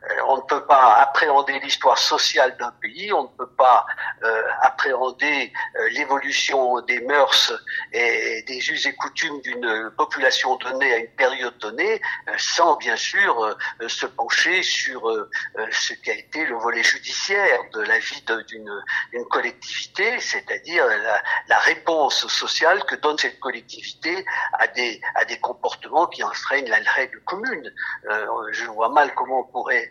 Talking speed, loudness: 140 wpm, -20 LUFS